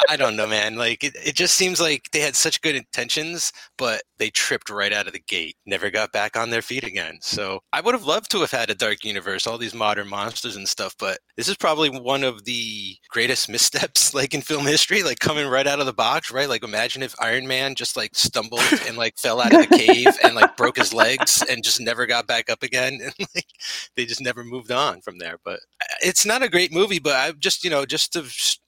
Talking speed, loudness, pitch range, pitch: 245 wpm, -20 LUFS, 115-165 Hz, 135 Hz